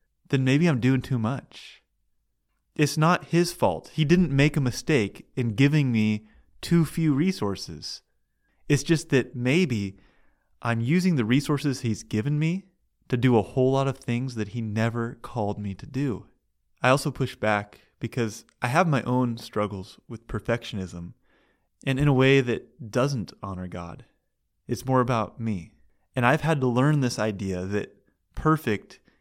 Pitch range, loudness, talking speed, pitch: 105-140 Hz, -25 LUFS, 160 wpm, 125 Hz